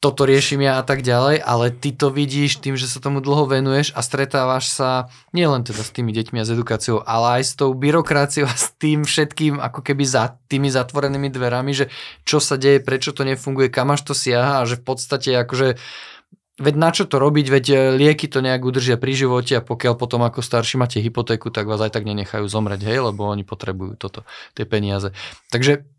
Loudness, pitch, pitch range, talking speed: -19 LUFS, 130 Hz, 120-140 Hz, 210 wpm